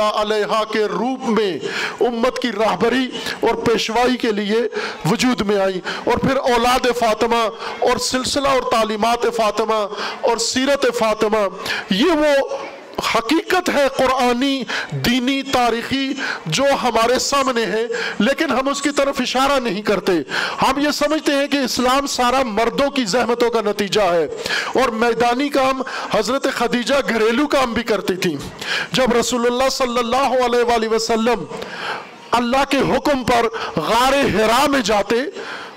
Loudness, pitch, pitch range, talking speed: -18 LUFS, 245 Hz, 225-270 Hz, 140 wpm